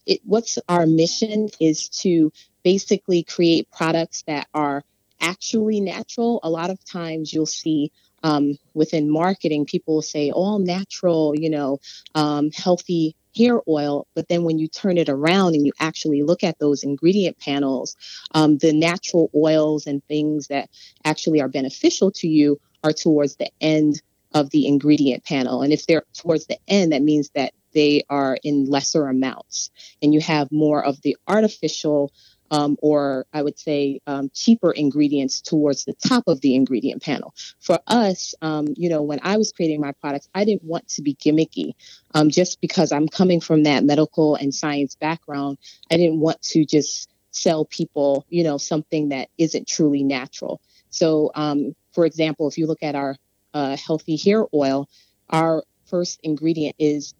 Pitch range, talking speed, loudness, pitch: 145-170 Hz, 170 wpm, -20 LUFS, 155 Hz